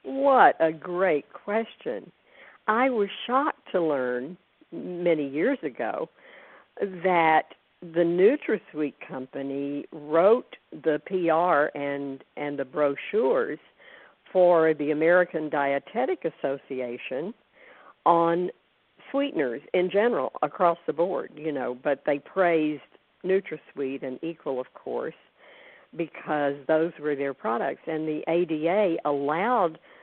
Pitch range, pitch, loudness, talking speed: 145-180 Hz, 160 Hz, -26 LUFS, 110 wpm